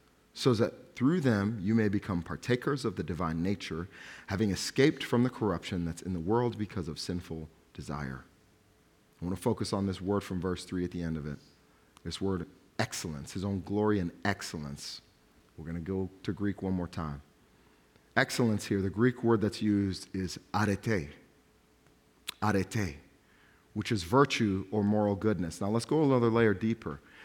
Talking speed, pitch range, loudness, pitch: 175 wpm, 85-110 Hz, -32 LUFS, 100 Hz